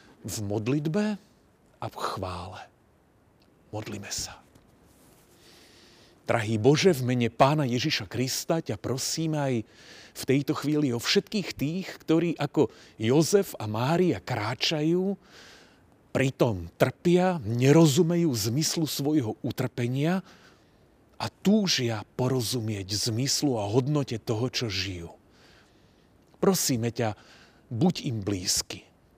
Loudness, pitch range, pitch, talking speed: -27 LUFS, 115-160 Hz, 130 Hz, 100 wpm